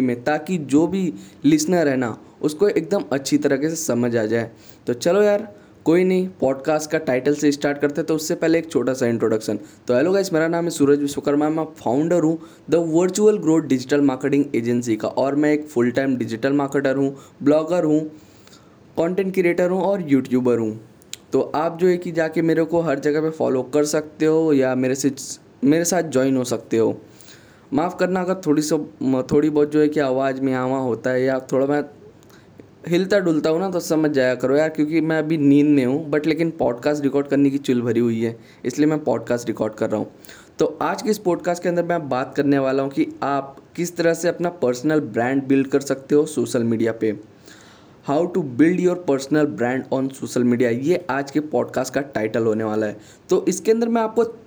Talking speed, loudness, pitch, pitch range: 210 wpm, -20 LUFS, 145 Hz, 130-165 Hz